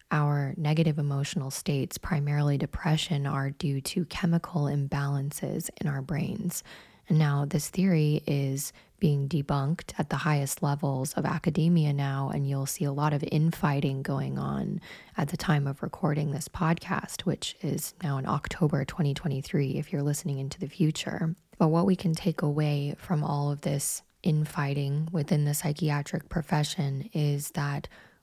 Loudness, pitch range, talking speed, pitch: -29 LUFS, 145-170 Hz, 155 wpm, 150 Hz